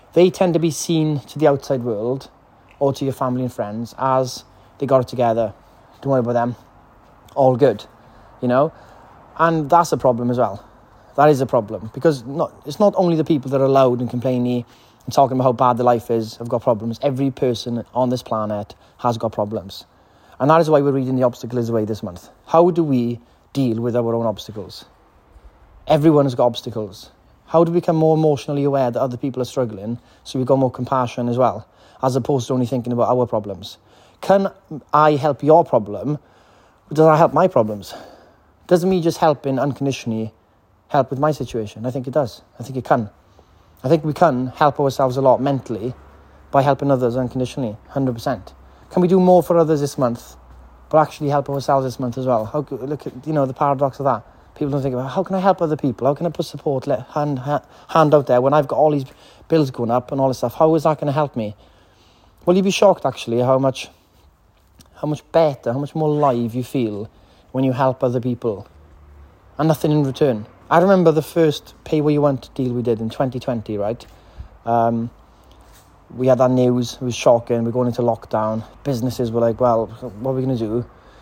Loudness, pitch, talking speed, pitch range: -19 LUFS, 125 Hz, 210 wpm, 115-145 Hz